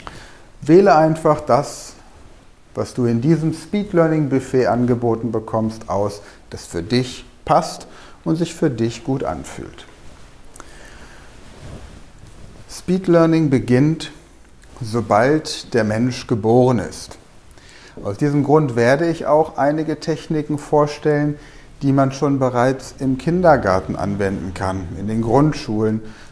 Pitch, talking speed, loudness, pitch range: 130 Hz, 110 wpm, -18 LUFS, 110-150 Hz